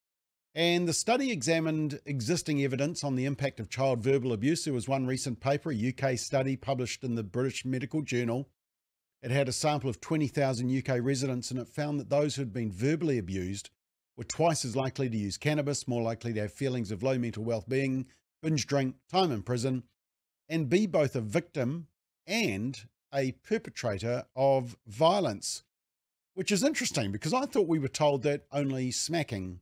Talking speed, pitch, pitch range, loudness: 180 wpm, 135 Hz, 120-150 Hz, -31 LUFS